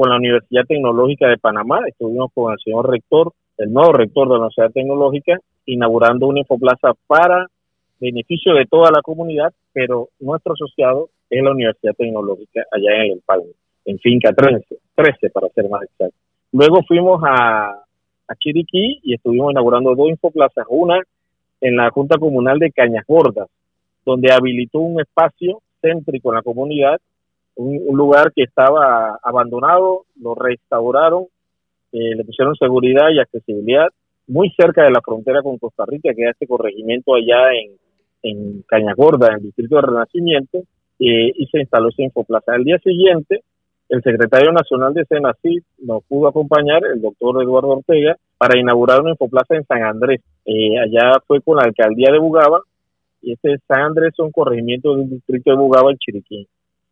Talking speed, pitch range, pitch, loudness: 170 wpm, 115-155 Hz, 130 Hz, -14 LUFS